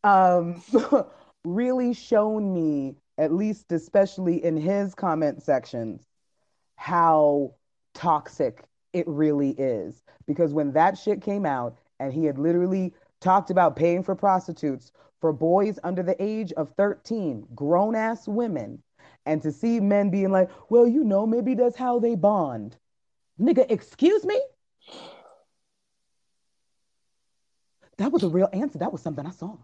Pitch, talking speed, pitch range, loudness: 185 Hz, 140 wpm, 160-215 Hz, -24 LUFS